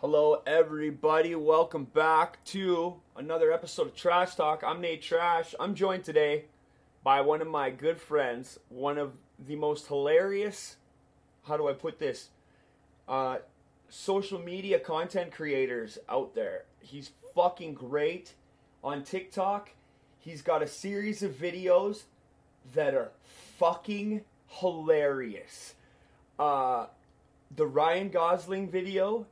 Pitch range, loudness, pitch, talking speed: 145-190 Hz, -30 LUFS, 160 Hz, 120 wpm